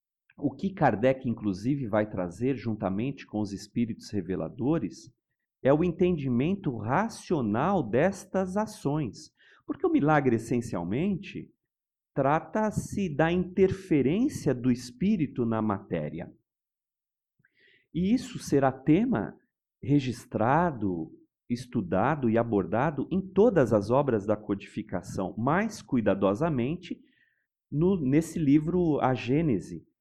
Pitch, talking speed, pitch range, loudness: 140 Hz, 100 wpm, 115-180 Hz, -28 LUFS